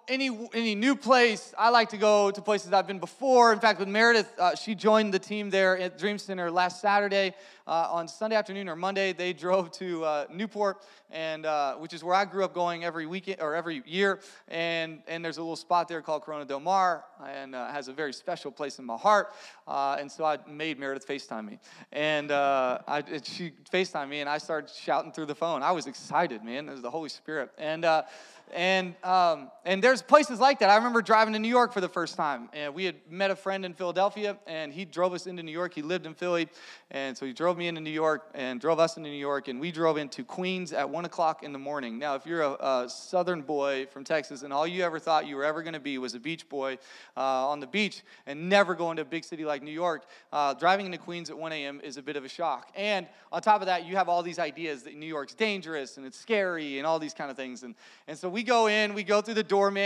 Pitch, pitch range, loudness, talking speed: 170 Hz, 150-195 Hz, -28 LUFS, 255 wpm